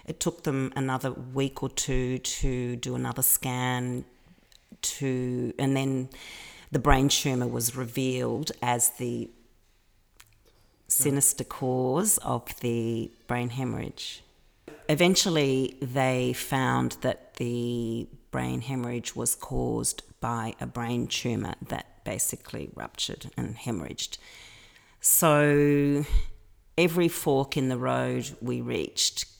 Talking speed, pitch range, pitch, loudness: 110 wpm, 120-140 Hz, 130 Hz, -27 LUFS